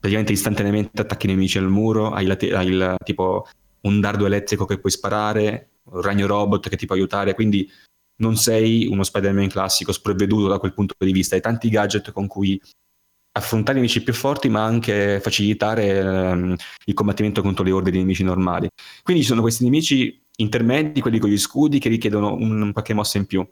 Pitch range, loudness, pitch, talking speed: 95-110 Hz, -20 LUFS, 100 Hz, 195 wpm